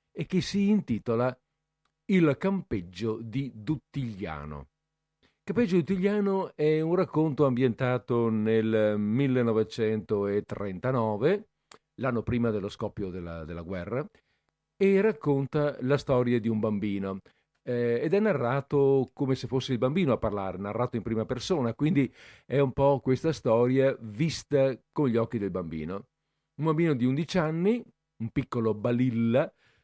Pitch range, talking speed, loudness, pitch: 110-155 Hz, 135 wpm, -28 LUFS, 130 Hz